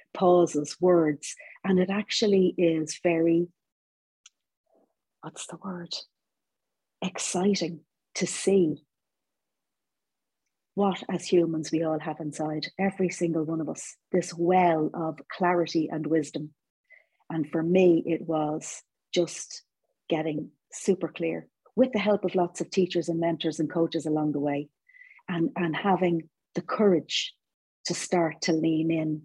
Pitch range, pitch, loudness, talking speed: 160-180 Hz, 170 Hz, -27 LUFS, 130 wpm